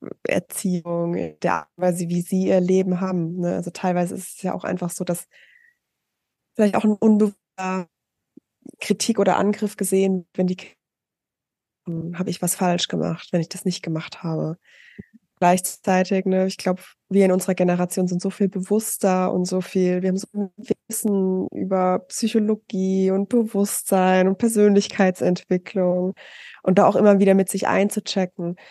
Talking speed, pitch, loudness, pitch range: 155 wpm, 185 Hz, -21 LUFS, 180-200 Hz